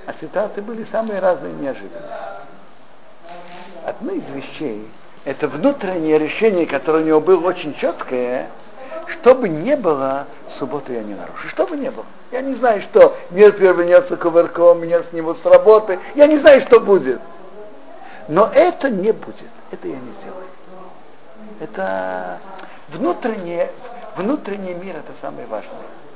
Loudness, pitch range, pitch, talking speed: -16 LUFS, 160-225 Hz, 185 Hz, 140 wpm